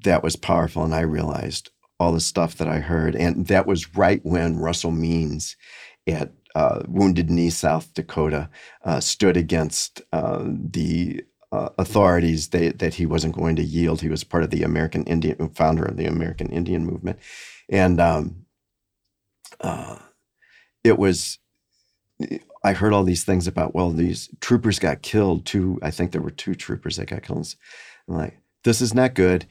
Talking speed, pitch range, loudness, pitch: 170 wpm, 80-95 Hz, -22 LUFS, 85 Hz